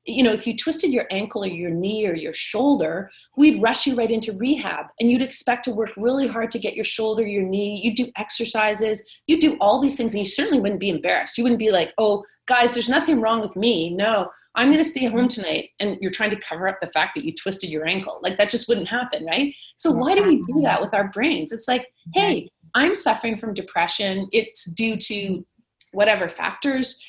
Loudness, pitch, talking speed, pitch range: -21 LUFS, 225 Hz, 230 wpm, 200-255 Hz